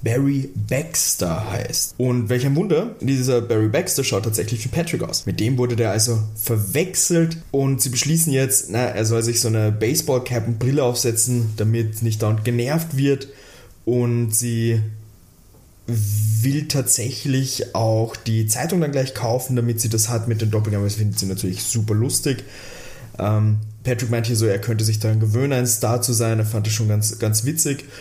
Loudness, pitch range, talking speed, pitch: -20 LUFS, 110-130 Hz, 180 wpm, 120 Hz